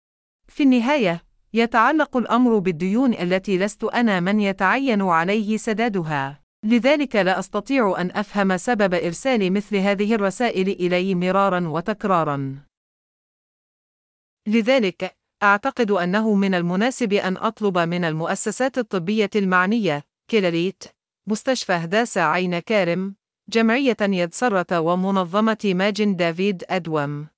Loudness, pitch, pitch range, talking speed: -21 LUFS, 200 Hz, 180-225 Hz, 105 wpm